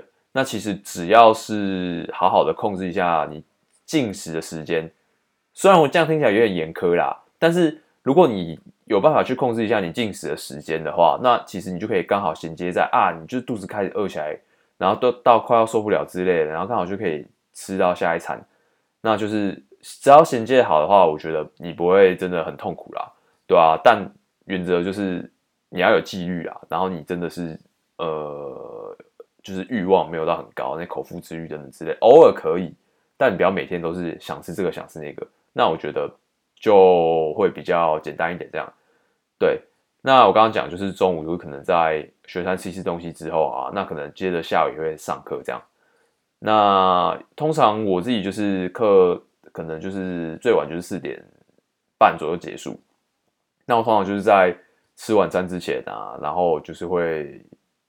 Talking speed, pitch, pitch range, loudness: 280 characters per minute, 95 Hz, 85-125 Hz, -20 LUFS